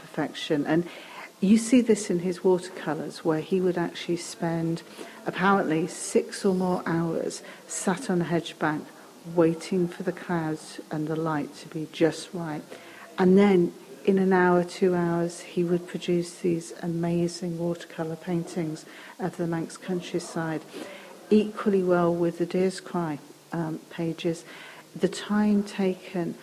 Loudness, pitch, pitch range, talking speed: -27 LUFS, 175 Hz, 165-185 Hz, 145 wpm